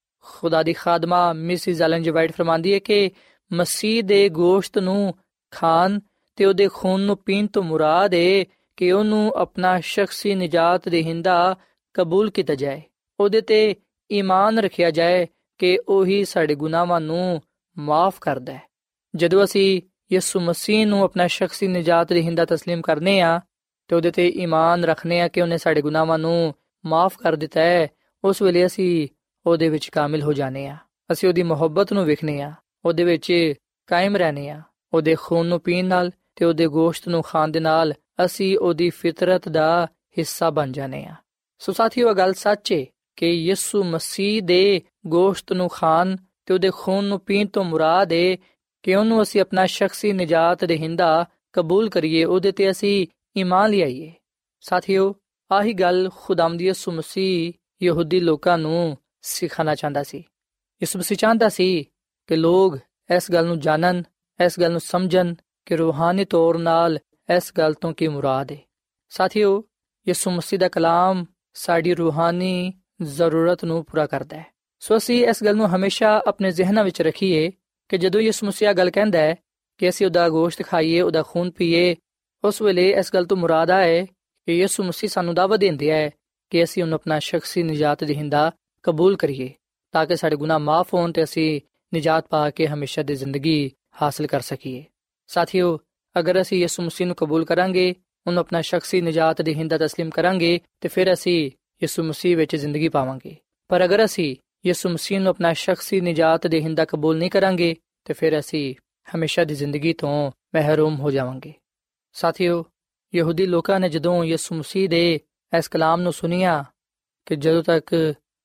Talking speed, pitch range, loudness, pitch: 165 wpm, 160-190 Hz, -20 LUFS, 175 Hz